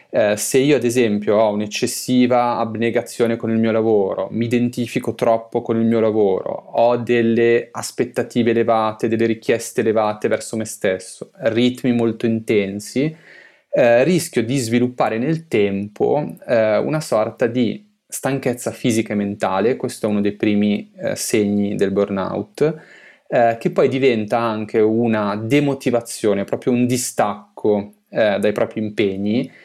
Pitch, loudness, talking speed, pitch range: 115 Hz, -19 LUFS, 140 wpm, 105-120 Hz